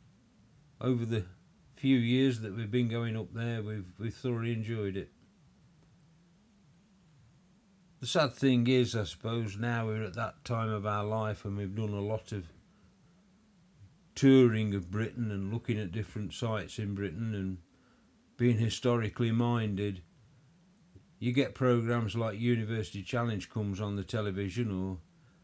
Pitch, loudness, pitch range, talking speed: 115 Hz, -32 LUFS, 105-130 Hz, 140 wpm